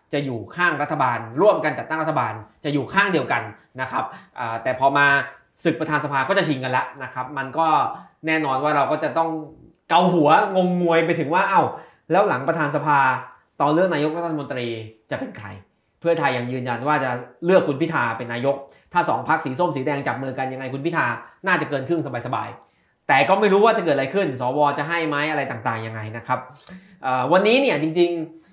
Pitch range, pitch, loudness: 130-170 Hz, 145 Hz, -21 LUFS